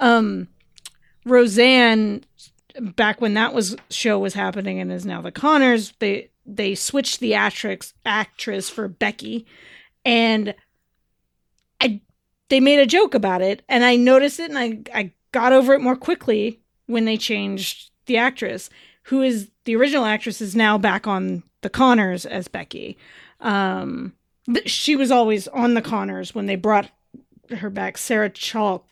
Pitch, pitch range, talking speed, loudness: 225 Hz, 210-250 Hz, 155 wpm, -19 LUFS